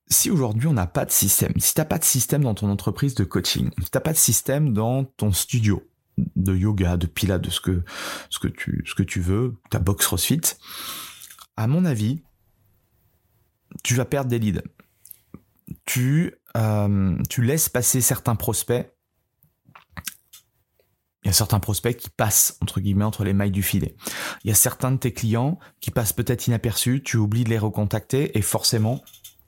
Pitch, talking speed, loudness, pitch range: 110 Hz, 185 wpm, -22 LUFS, 100-125 Hz